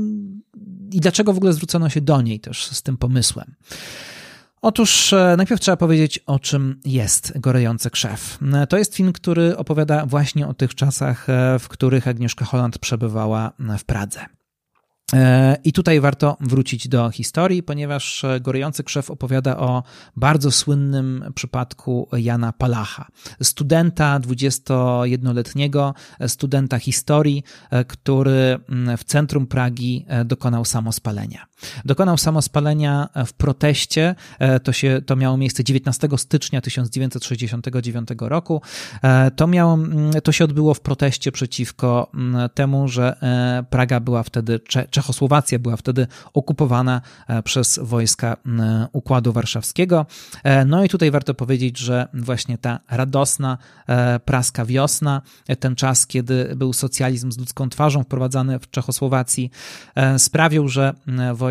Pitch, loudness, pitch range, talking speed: 130 Hz, -19 LUFS, 125-145 Hz, 120 wpm